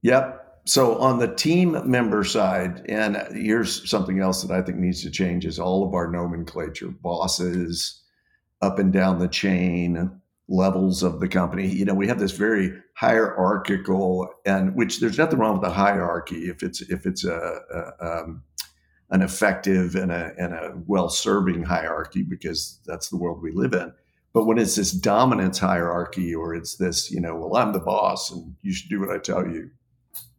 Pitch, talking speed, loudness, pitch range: 95 Hz, 185 wpm, -23 LUFS, 90-100 Hz